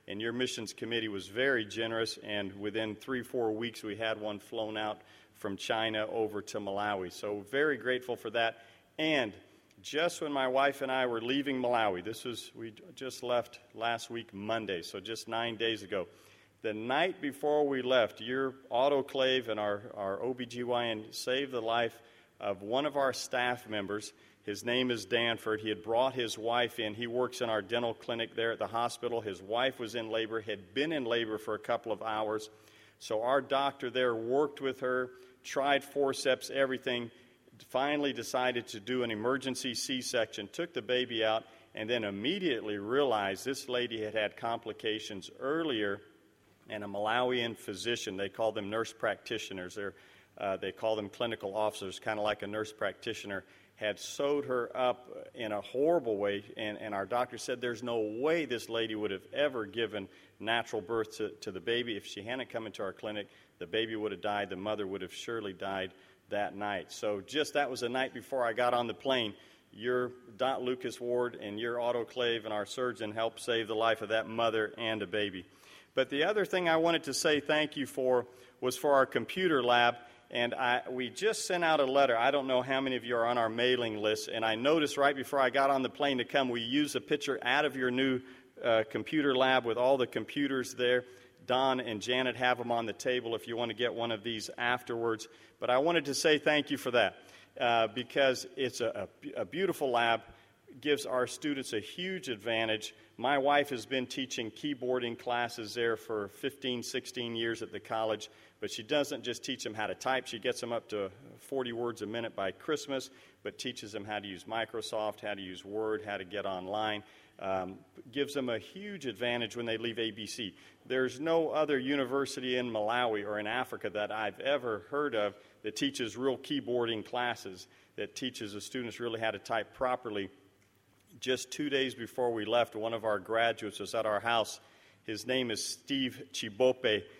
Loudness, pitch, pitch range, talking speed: -33 LUFS, 120 Hz, 110-130 Hz, 195 wpm